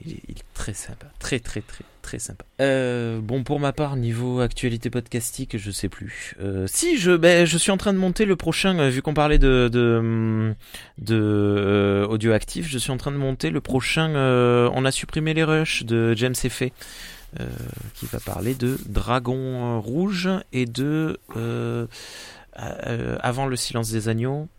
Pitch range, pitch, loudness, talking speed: 115-150 Hz, 125 Hz, -22 LUFS, 185 wpm